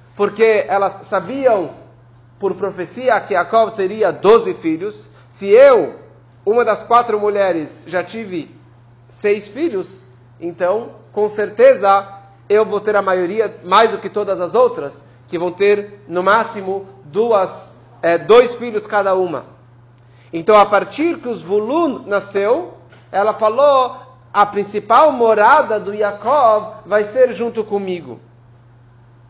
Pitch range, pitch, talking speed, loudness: 170-225 Hz, 200 Hz, 125 wpm, -15 LUFS